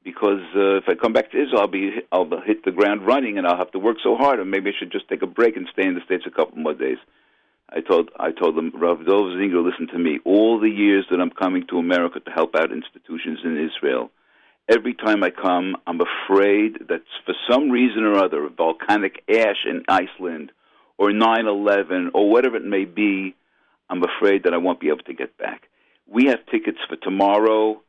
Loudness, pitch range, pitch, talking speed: -20 LUFS, 95-105 Hz, 100 Hz, 225 wpm